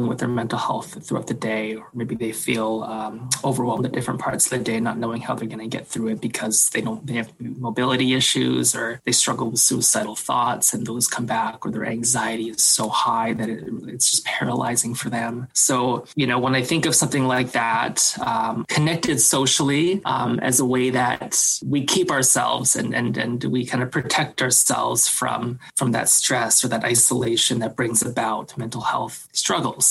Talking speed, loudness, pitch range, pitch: 200 wpm, -20 LUFS, 115-130 Hz, 120 Hz